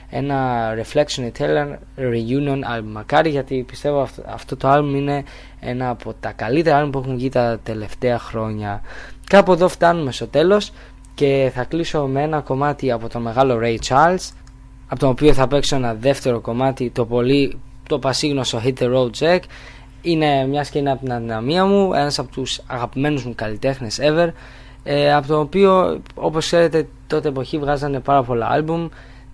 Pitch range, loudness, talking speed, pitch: 125-145 Hz, -19 LUFS, 170 wpm, 135 Hz